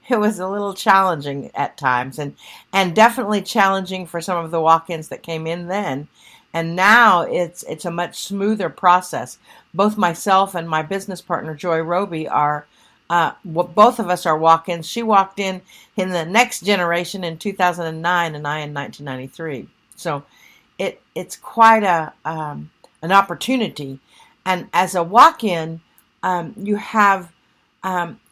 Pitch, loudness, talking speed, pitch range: 175 Hz, -18 LUFS, 155 wpm, 165-195 Hz